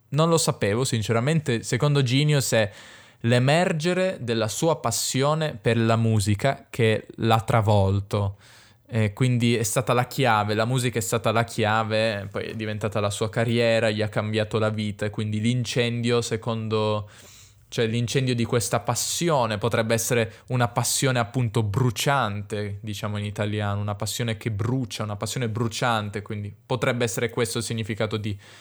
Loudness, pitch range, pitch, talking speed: -24 LUFS, 110-125 Hz, 115 Hz, 150 wpm